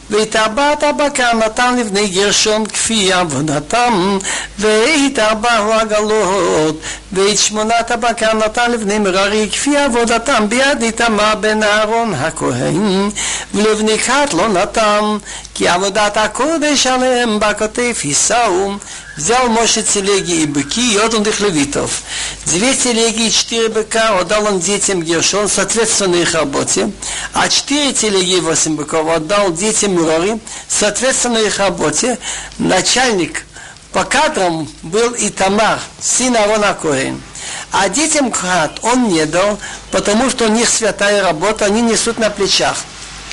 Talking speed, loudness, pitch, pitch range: 125 wpm, -13 LUFS, 215 Hz, 195-230 Hz